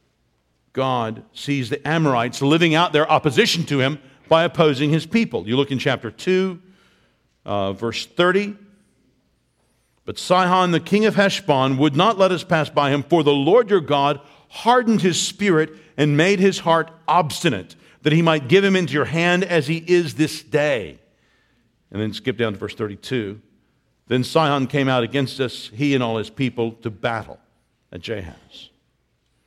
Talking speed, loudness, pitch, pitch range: 170 wpm, -19 LUFS, 150 Hz, 130-175 Hz